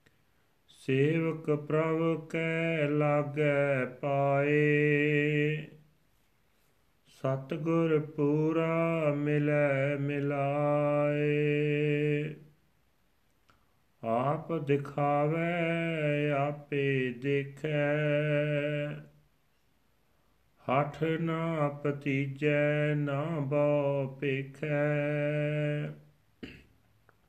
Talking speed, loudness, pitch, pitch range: 40 wpm, -30 LUFS, 145 Hz, 145-150 Hz